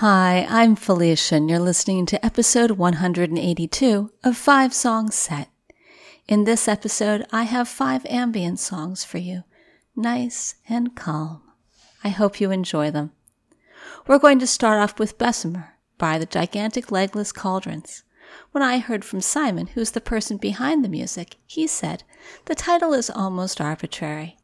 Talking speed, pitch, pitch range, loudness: 150 wpm, 210 Hz, 180-245 Hz, -21 LUFS